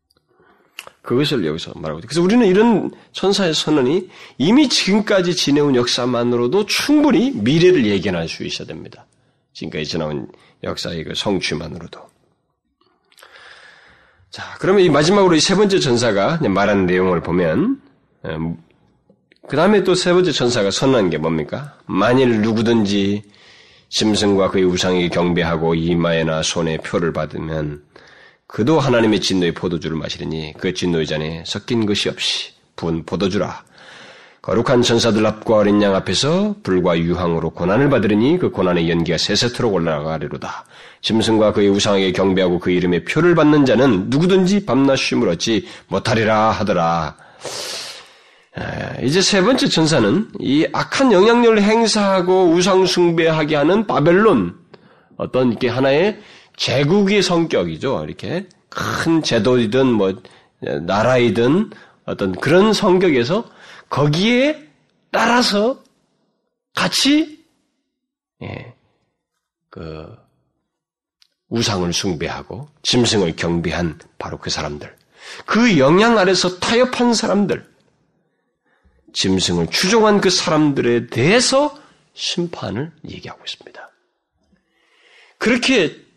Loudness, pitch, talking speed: -16 LUFS, 125 Hz, 275 characters per minute